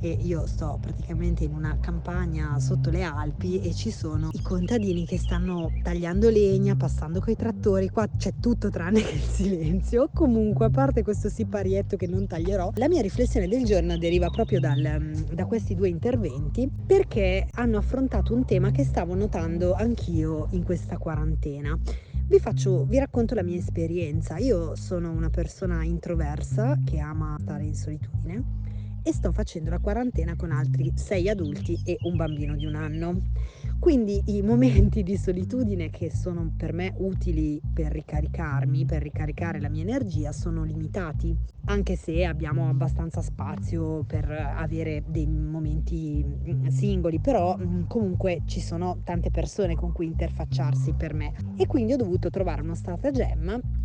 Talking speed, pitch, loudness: 155 wpm, 100 Hz, -26 LUFS